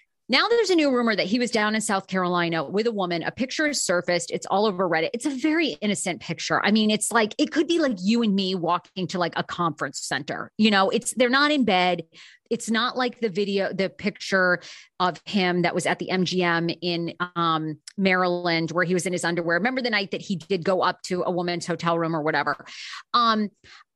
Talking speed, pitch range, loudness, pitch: 230 wpm, 175-220 Hz, -24 LUFS, 185 Hz